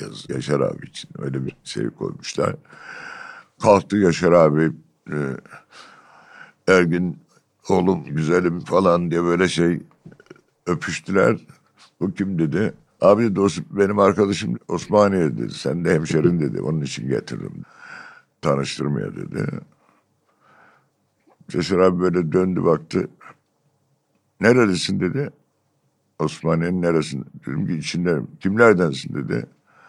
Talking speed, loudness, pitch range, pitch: 105 wpm, -20 LUFS, 80-100 Hz, 90 Hz